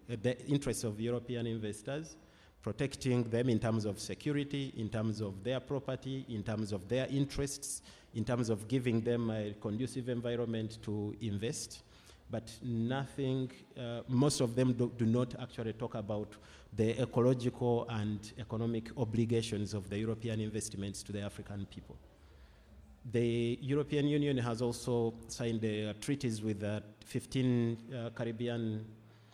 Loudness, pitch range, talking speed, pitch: -36 LUFS, 105-125 Hz, 145 wpm, 115 Hz